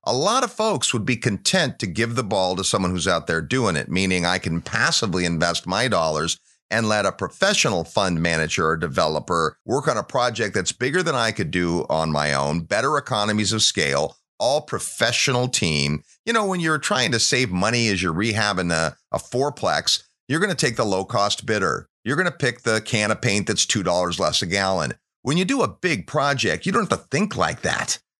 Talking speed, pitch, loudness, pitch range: 215 wpm, 105 Hz, -21 LUFS, 90-125 Hz